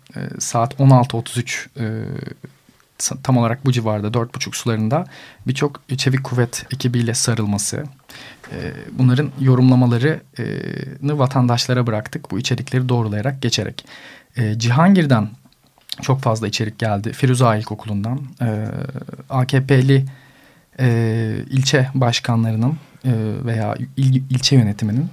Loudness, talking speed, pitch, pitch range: -18 LUFS, 85 wpm, 125 Hz, 115-135 Hz